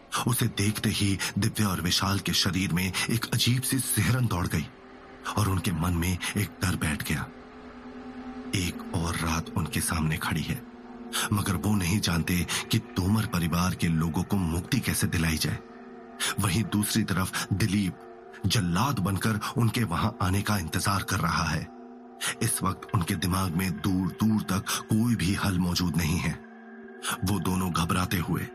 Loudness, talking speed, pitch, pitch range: -27 LUFS, 160 wpm, 95 Hz, 85-110 Hz